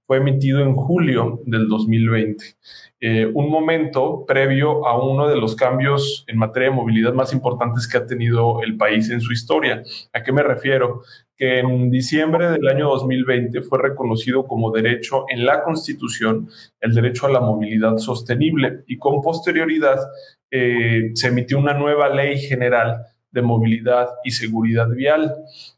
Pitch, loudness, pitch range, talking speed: 125 Hz, -18 LUFS, 115-140 Hz, 155 wpm